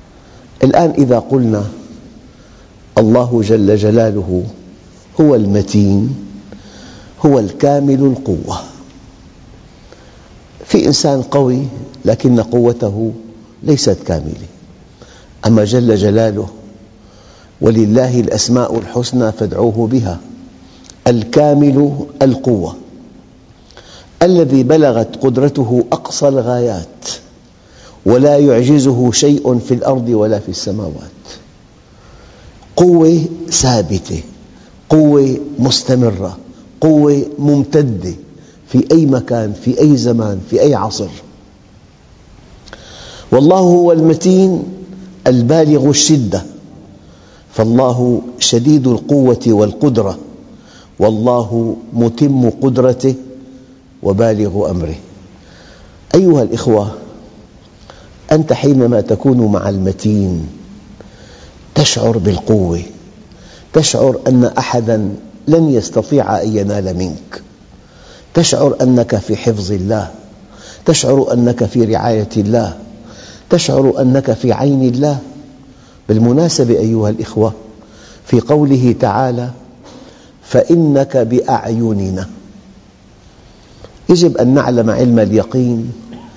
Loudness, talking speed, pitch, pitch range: -12 LUFS, 80 wpm, 120 Hz, 105-135 Hz